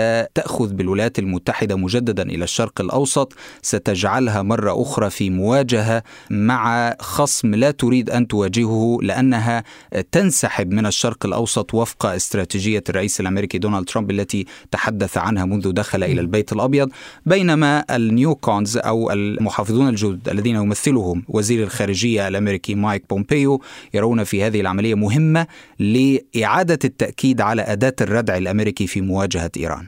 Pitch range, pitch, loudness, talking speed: 100-125 Hz, 110 Hz, -19 LUFS, 130 wpm